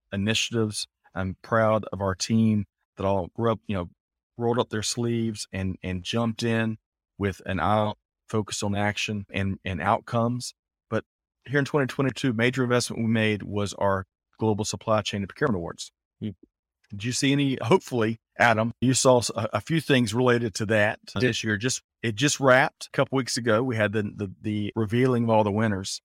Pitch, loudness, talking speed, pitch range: 110 Hz, -25 LUFS, 185 wpm, 105-120 Hz